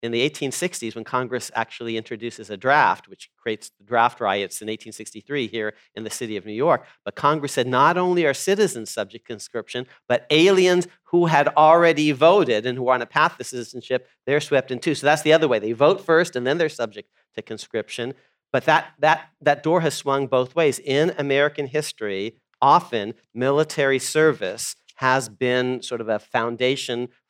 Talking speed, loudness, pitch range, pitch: 190 wpm, -21 LUFS, 120-155 Hz, 135 Hz